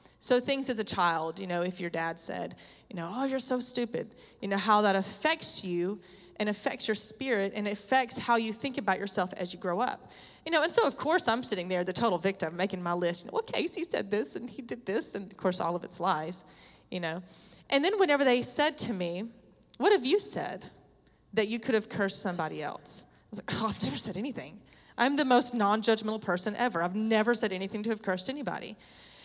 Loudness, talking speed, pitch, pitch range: -30 LUFS, 230 wpm, 210 Hz, 185-250 Hz